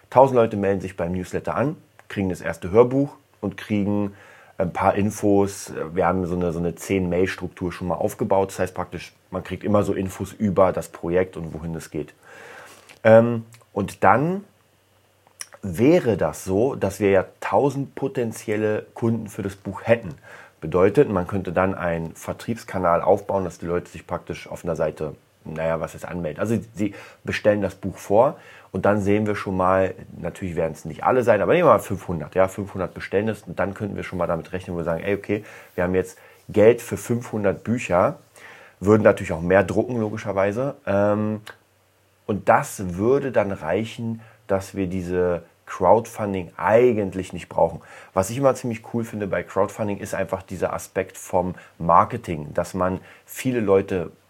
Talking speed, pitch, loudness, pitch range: 175 wpm, 95 Hz, -23 LUFS, 90-110 Hz